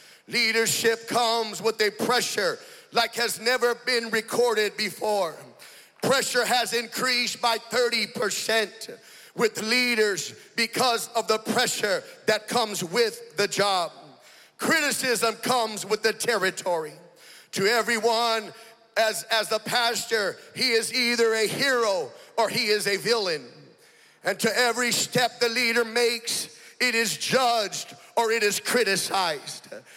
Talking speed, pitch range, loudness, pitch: 125 wpm, 220-245 Hz, -24 LUFS, 230 Hz